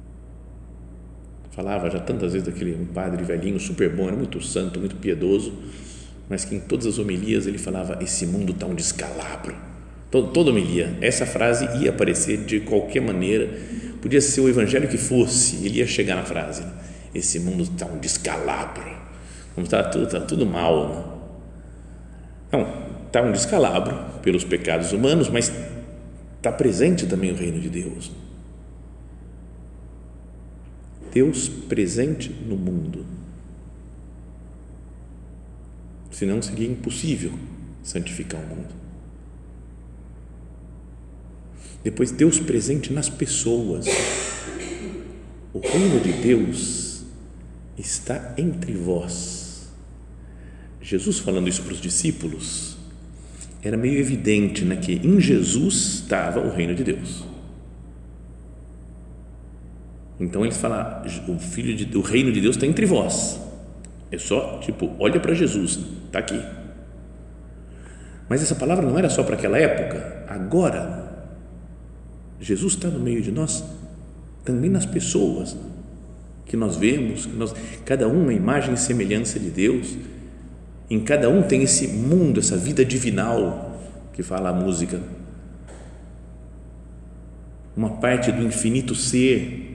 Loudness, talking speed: -22 LUFS, 125 wpm